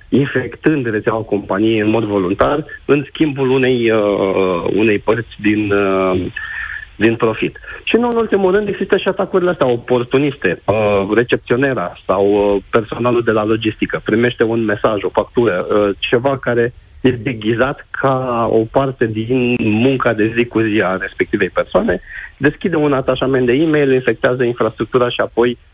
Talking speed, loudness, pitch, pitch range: 150 wpm, -16 LUFS, 120 Hz, 105-130 Hz